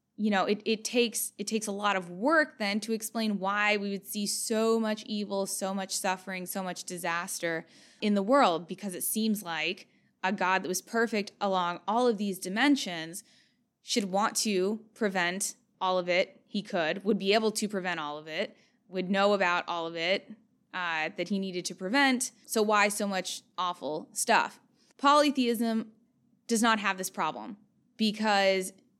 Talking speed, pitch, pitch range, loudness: 180 wpm, 205 Hz, 185-225 Hz, -29 LUFS